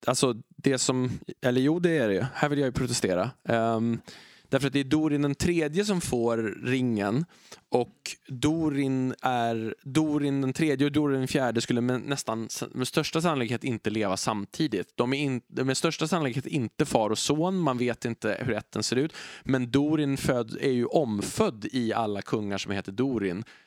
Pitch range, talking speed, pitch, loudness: 115-145 Hz, 170 wpm, 130 Hz, -27 LUFS